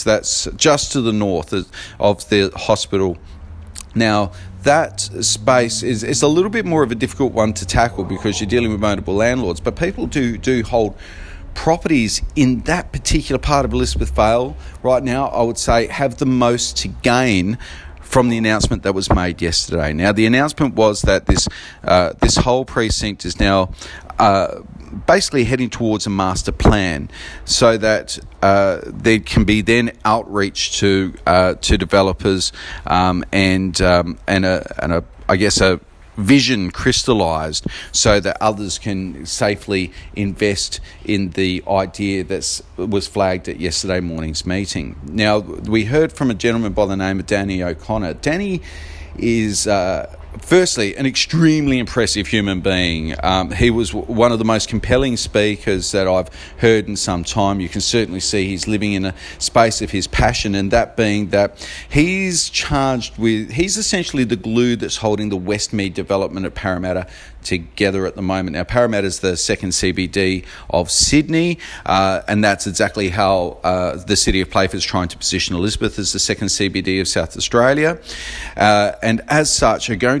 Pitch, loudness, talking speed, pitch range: 105 Hz, -17 LUFS, 170 wpm, 95-115 Hz